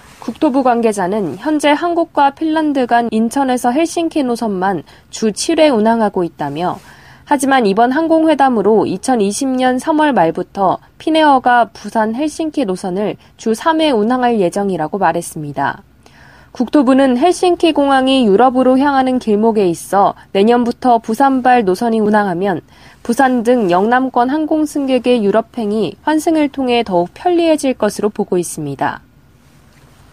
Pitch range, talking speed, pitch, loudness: 205-285 Hz, 295 characters per minute, 245 Hz, -14 LUFS